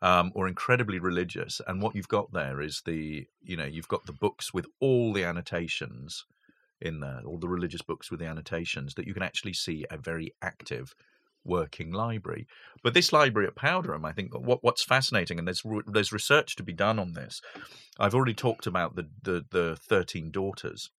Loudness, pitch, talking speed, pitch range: -29 LUFS, 90 Hz, 195 wpm, 85-110 Hz